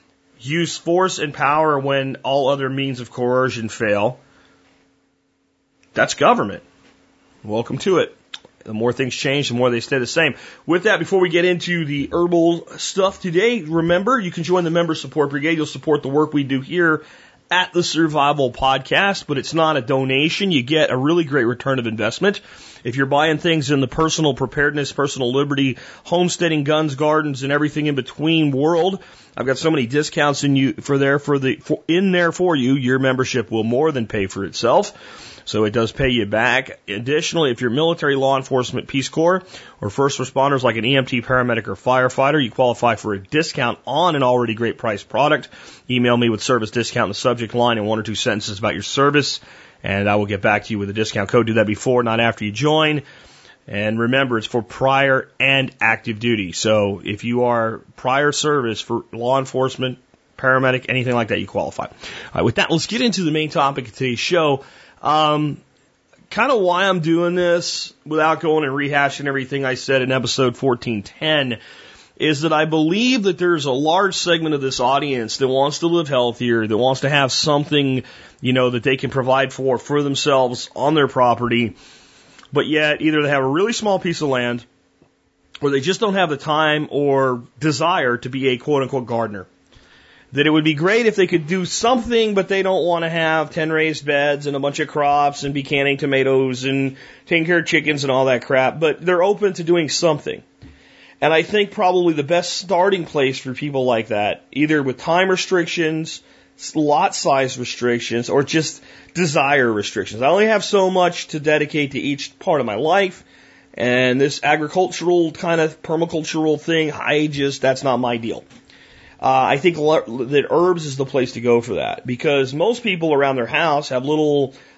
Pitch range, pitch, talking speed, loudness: 125-160 Hz, 140 Hz, 195 wpm, -18 LUFS